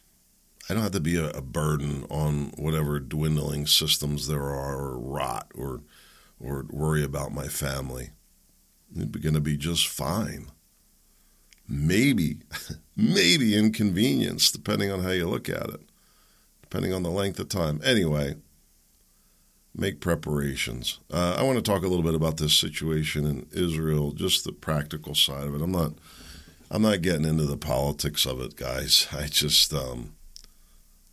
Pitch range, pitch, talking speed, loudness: 70-80 Hz, 75 Hz, 155 wpm, -26 LUFS